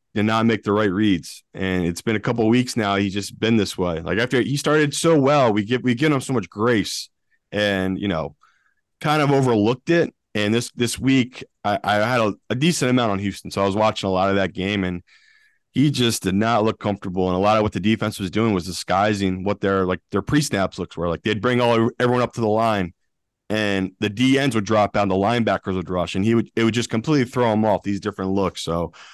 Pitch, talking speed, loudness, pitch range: 105 Hz, 250 wpm, -21 LUFS, 95-120 Hz